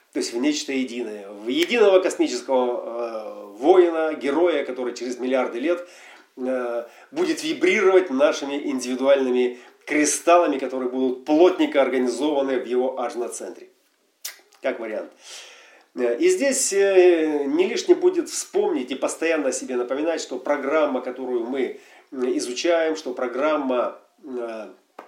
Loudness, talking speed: -22 LUFS, 120 wpm